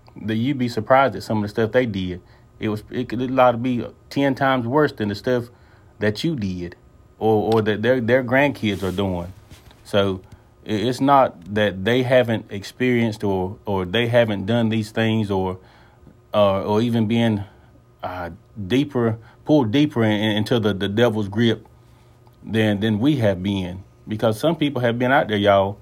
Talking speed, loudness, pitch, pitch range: 185 wpm, -20 LUFS, 110 Hz, 105-125 Hz